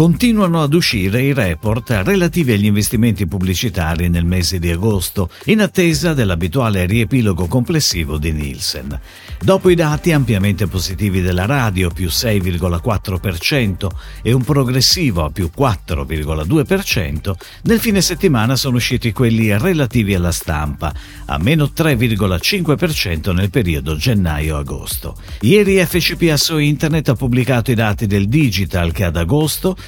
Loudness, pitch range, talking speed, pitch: -16 LUFS, 90-145 Hz, 125 wpm, 105 Hz